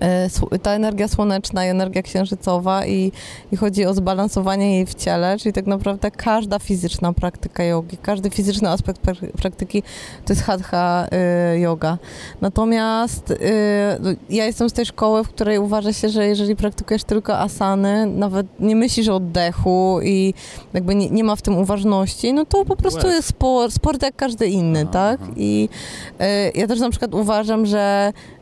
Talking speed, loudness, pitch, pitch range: 160 wpm, -19 LUFS, 200 Hz, 185-215 Hz